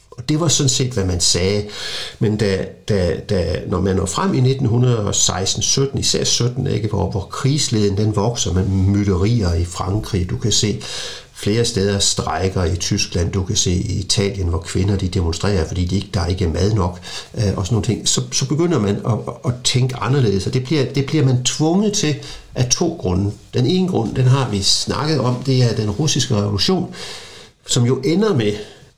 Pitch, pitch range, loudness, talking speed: 105 Hz, 95-130 Hz, -18 LUFS, 195 wpm